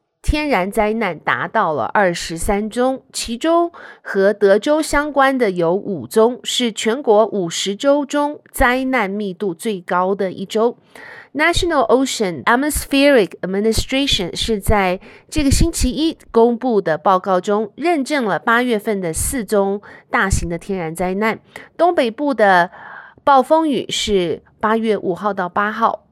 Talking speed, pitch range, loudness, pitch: 275 characters per minute, 195-270 Hz, -17 LUFS, 220 Hz